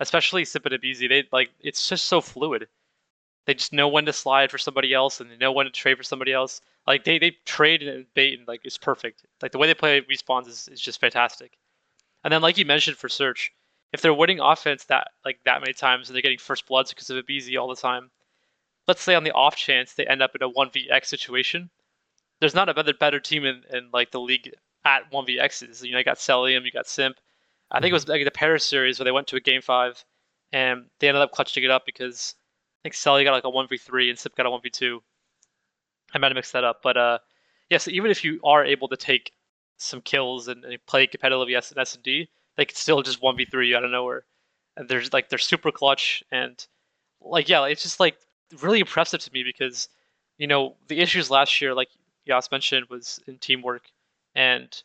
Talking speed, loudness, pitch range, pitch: 235 wpm, -22 LUFS, 125-145 Hz, 130 Hz